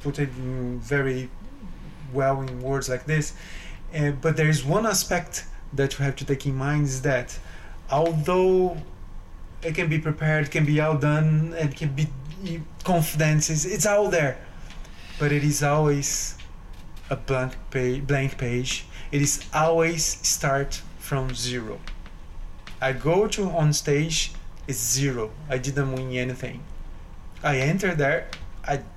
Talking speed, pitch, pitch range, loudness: 140 wpm, 140 Hz, 125-155 Hz, -24 LUFS